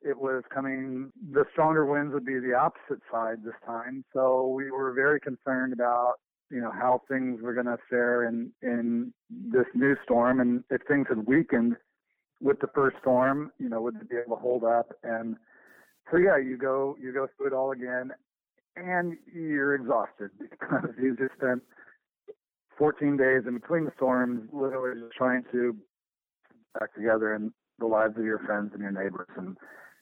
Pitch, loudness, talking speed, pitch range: 130 Hz, -28 LUFS, 180 wpm, 120-140 Hz